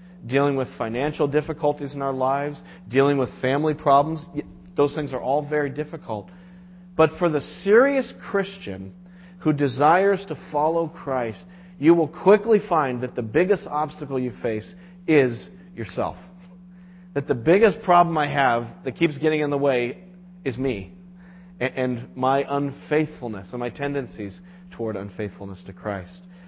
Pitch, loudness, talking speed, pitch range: 145 Hz, -23 LUFS, 145 wpm, 130-180 Hz